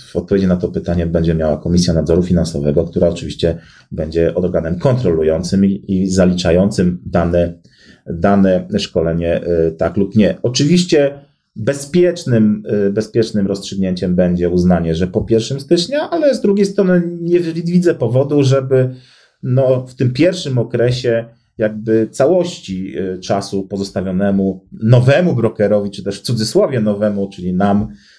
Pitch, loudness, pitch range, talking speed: 105 Hz, -15 LUFS, 90-130 Hz, 130 wpm